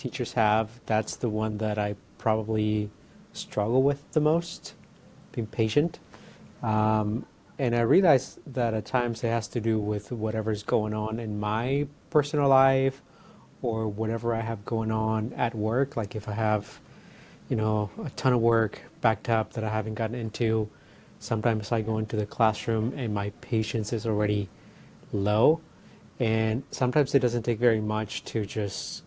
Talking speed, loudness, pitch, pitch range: 165 wpm, -27 LUFS, 110 Hz, 110-125 Hz